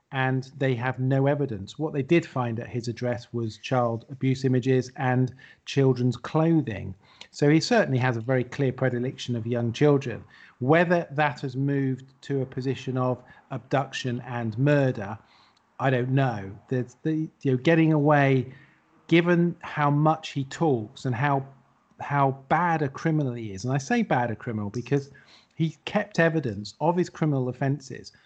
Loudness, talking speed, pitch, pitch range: -26 LUFS, 165 wpm, 135 Hz, 125-150 Hz